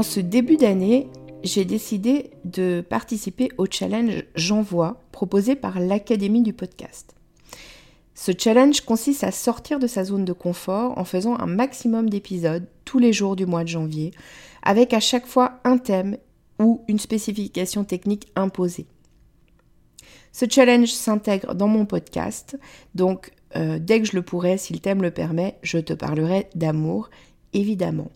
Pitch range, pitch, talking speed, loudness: 185-235 Hz, 205 Hz, 155 wpm, -22 LUFS